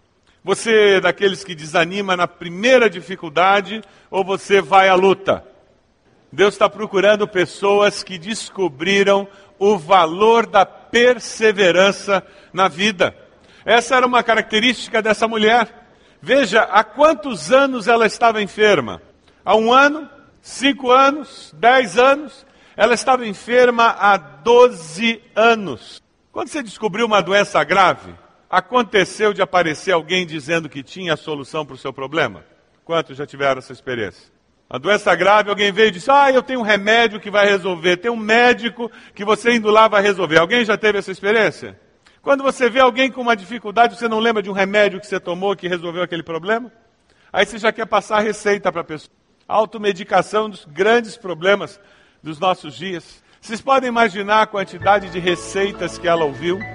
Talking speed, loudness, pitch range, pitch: 160 wpm, -16 LUFS, 185-230 Hz, 205 Hz